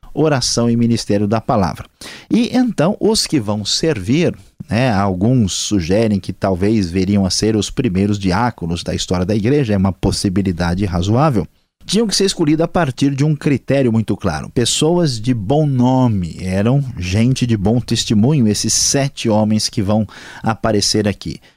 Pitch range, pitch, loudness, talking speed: 100-135 Hz, 110 Hz, -16 LUFS, 160 wpm